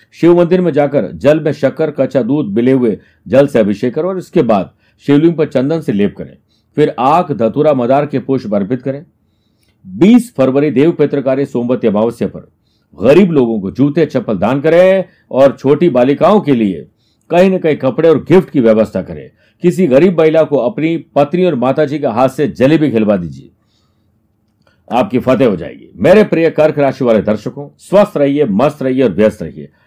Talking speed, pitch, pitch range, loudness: 185 wpm, 140 Hz, 115-160 Hz, -12 LUFS